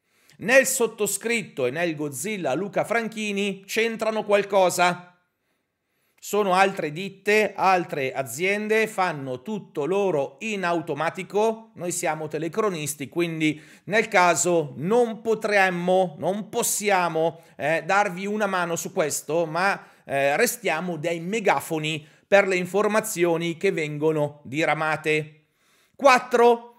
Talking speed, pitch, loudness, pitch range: 105 wpm, 185 Hz, -23 LUFS, 165-210 Hz